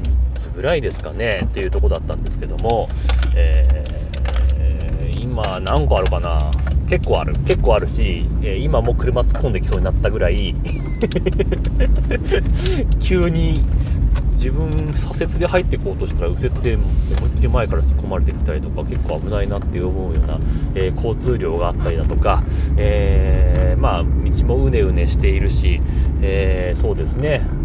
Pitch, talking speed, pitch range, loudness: 70 Hz, 320 characters per minute, 70-80 Hz, -19 LUFS